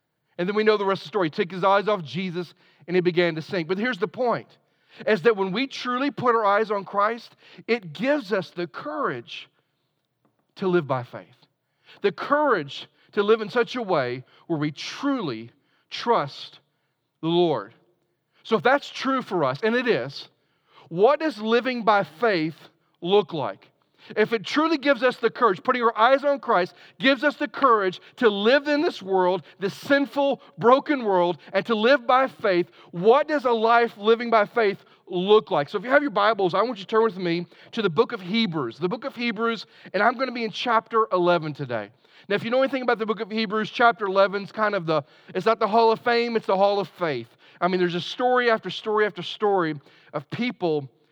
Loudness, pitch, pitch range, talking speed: -23 LUFS, 210 Hz, 175-235 Hz, 210 wpm